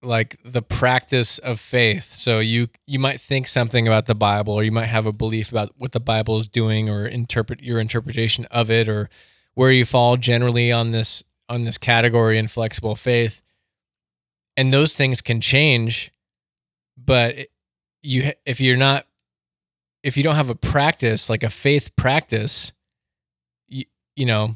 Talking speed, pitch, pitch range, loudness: 165 wpm, 115 Hz, 110-125 Hz, -19 LUFS